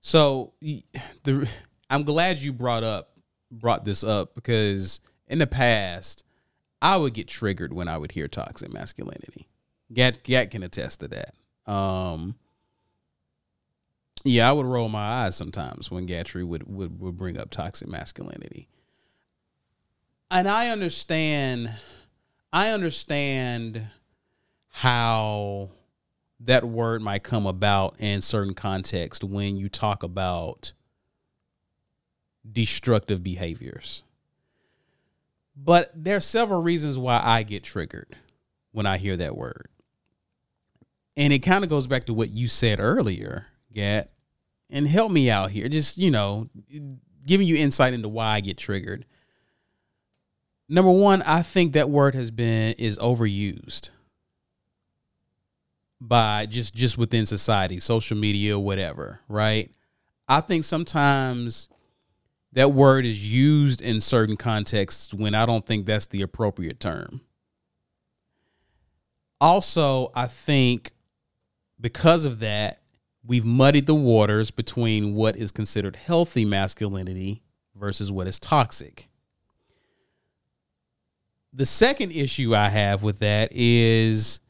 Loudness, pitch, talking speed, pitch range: -23 LUFS, 115 Hz, 125 wpm, 100-135 Hz